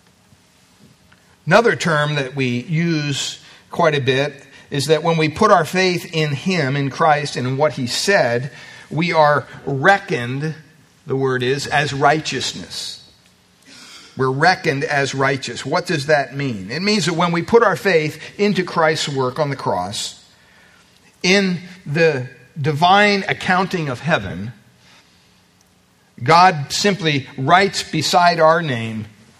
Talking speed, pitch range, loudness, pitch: 135 wpm, 135-170 Hz, -17 LUFS, 150 Hz